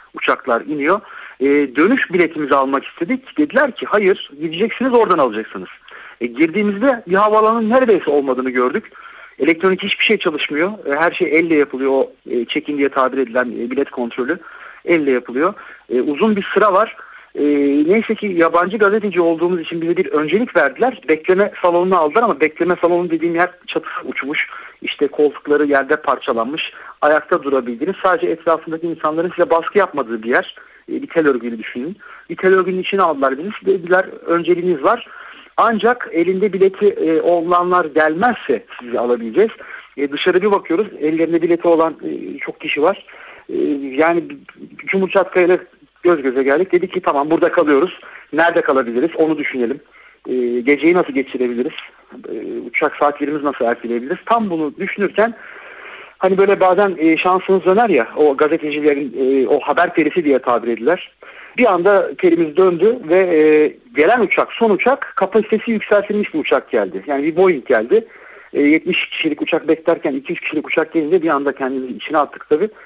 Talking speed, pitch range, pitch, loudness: 155 wpm, 145-205 Hz, 170 Hz, -16 LUFS